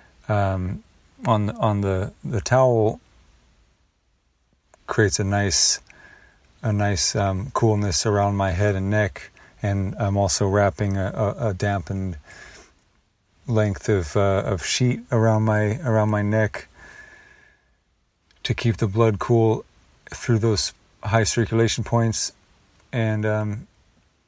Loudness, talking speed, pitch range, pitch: -22 LUFS, 120 wpm, 95-110 Hz, 105 Hz